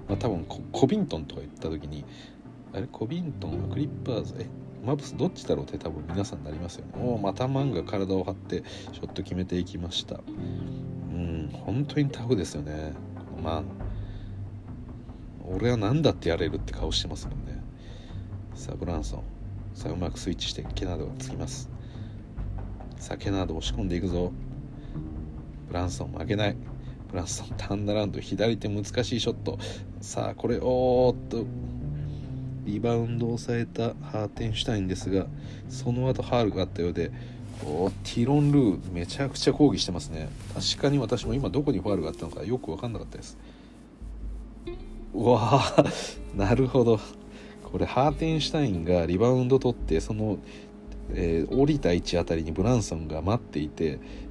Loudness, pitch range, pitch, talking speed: -29 LUFS, 90-125 Hz, 105 Hz, 360 characters per minute